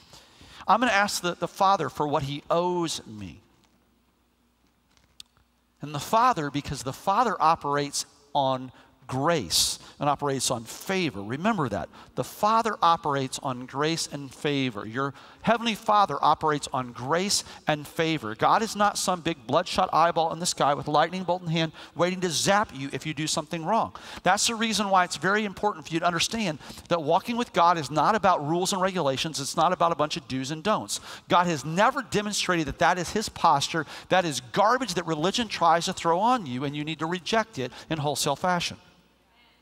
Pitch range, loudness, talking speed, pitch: 145-185 Hz, -26 LUFS, 190 wpm, 165 Hz